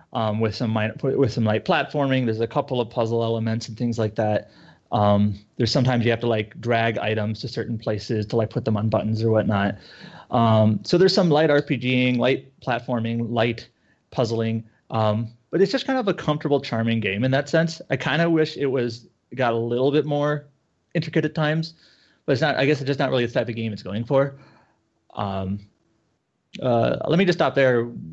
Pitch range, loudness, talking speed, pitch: 110-140 Hz, -22 LUFS, 210 wpm, 120 Hz